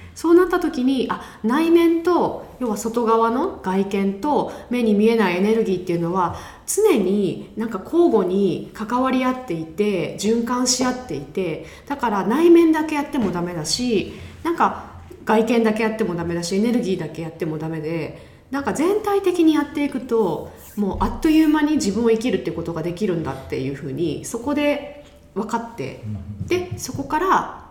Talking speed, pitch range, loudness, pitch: 355 characters per minute, 185-290 Hz, -20 LUFS, 225 Hz